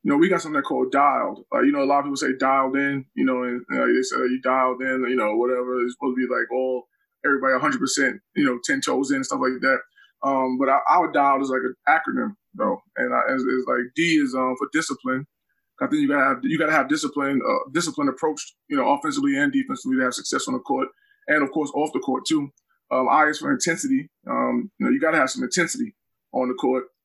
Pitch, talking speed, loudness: 145 Hz, 255 wpm, -22 LUFS